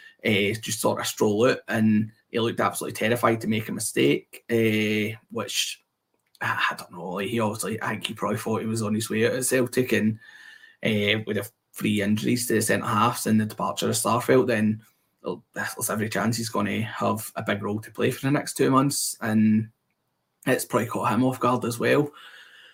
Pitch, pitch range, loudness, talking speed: 110 Hz, 110-125 Hz, -25 LUFS, 210 wpm